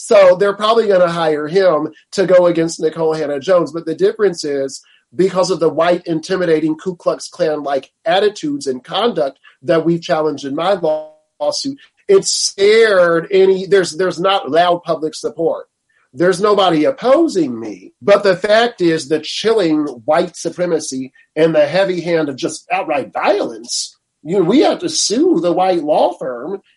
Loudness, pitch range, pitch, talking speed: -15 LUFS, 160-215 Hz, 180 Hz, 165 wpm